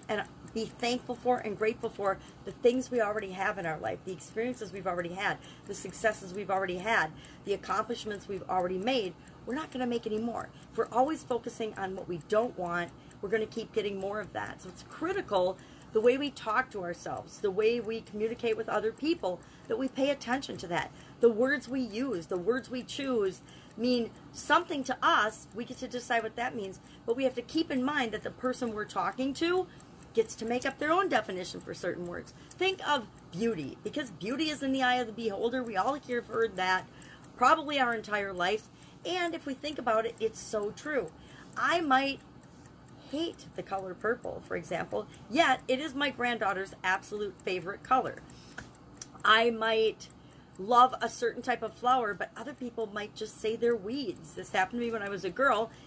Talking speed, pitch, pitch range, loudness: 200 wpm, 230 Hz, 200-255 Hz, -31 LUFS